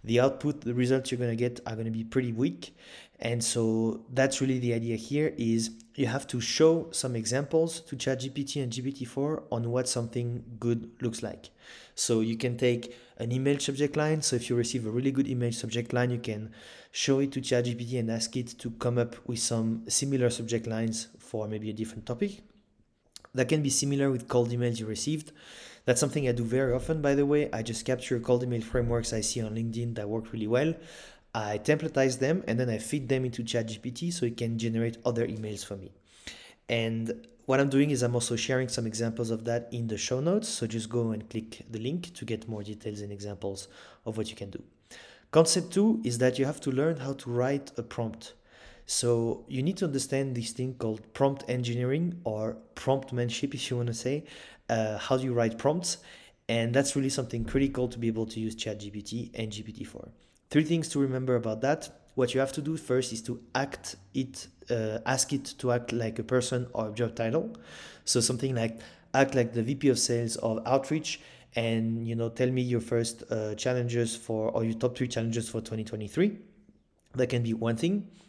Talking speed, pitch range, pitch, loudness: 210 wpm, 115-135 Hz, 120 Hz, -30 LUFS